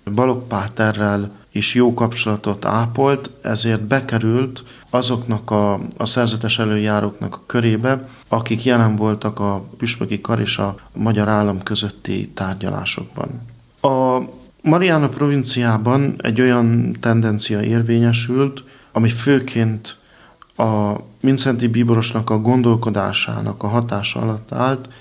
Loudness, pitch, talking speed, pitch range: -18 LUFS, 115 Hz, 110 wpm, 105-125 Hz